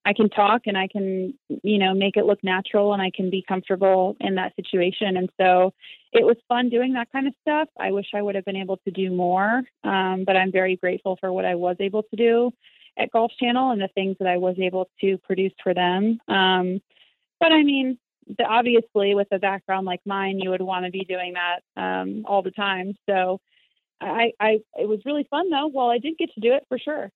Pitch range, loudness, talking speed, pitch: 185-235 Hz, -22 LUFS, 230 wpm, 195 Hz